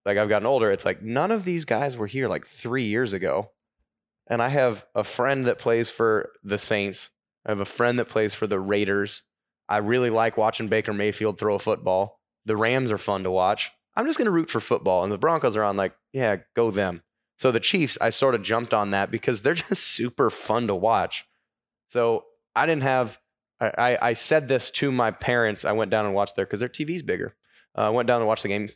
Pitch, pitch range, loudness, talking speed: 115 Hz, 105-130 Hz, -24 LUFS, 235 wpm